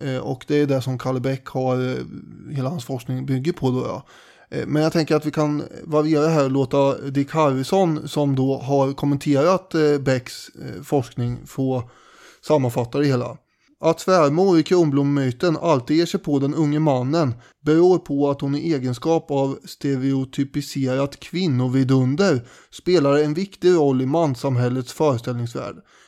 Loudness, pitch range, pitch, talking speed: -21 LUFS, 130-155 Hz, 140 Hz, 150 wpm